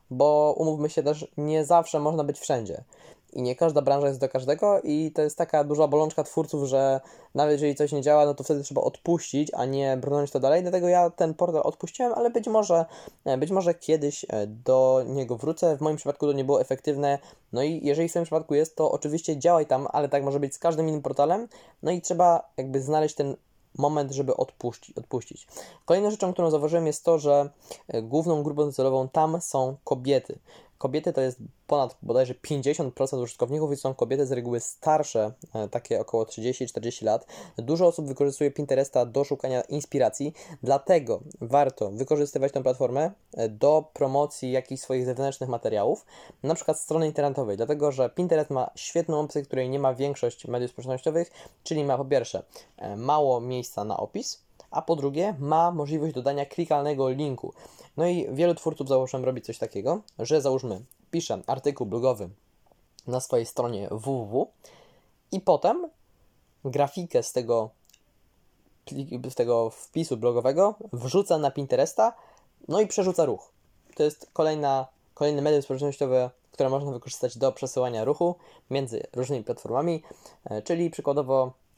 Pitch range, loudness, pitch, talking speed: 130-160 Hz, -26 LUFS, 145 Hz, 160 wpm